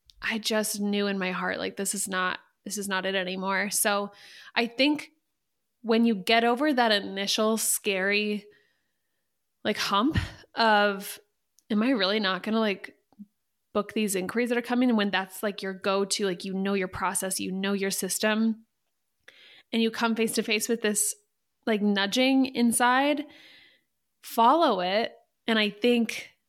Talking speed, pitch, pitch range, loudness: 160 wpm, 215 Hz, 200-235 Hz, -26 LUFS